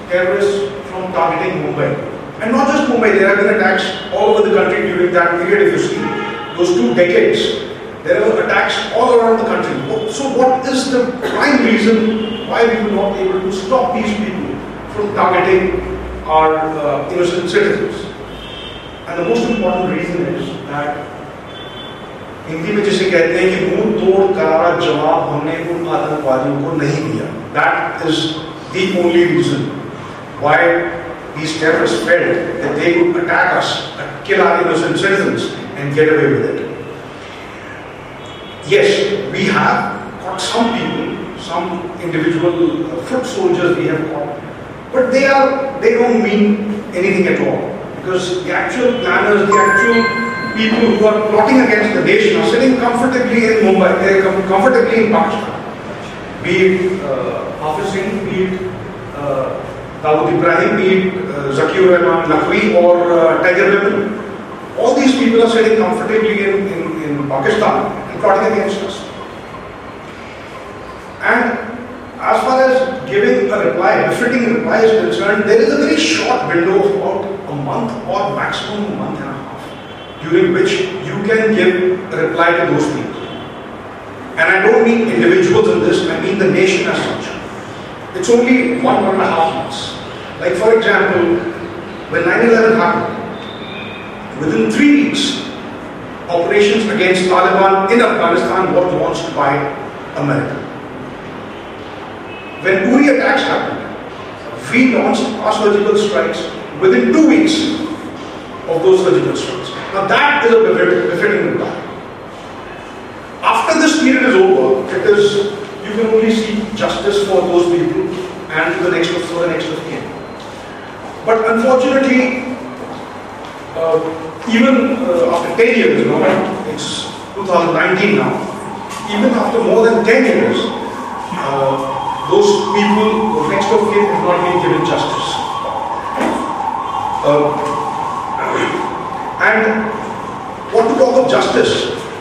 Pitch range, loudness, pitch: 175-245 Hz, -14 LUFS, 205 Hz